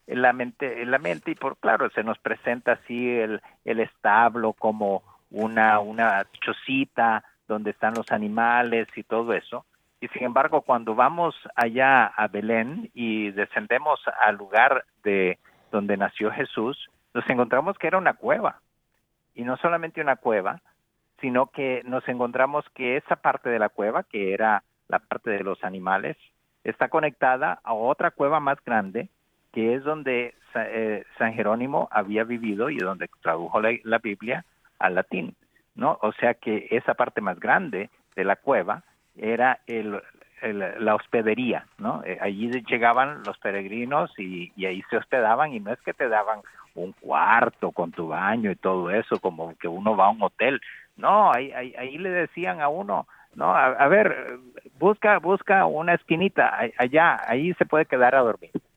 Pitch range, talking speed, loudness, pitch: 105-130 Hz, 165 wpm, -24 LUFS, 115 Hz